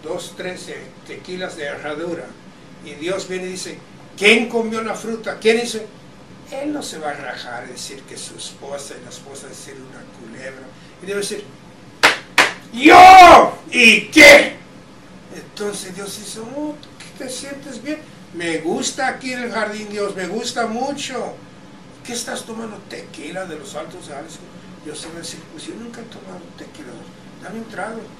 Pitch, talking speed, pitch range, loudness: 210 Hz, 170 wpm, 180-245 Hz, -13 LUFS